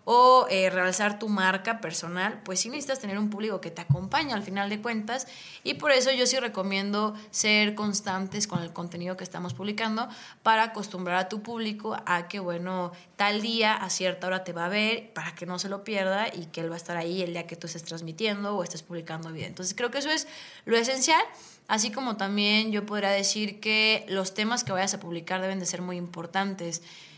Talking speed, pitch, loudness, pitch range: 220 wpm, 195 Hz, -27 LUFS, 180-220 Hz